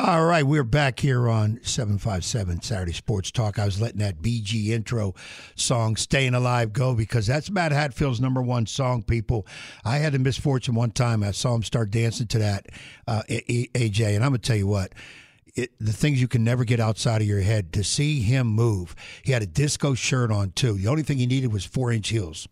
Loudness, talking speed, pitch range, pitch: -24 LUFS, 215 wpm, 110-130 Hz, 115 Hz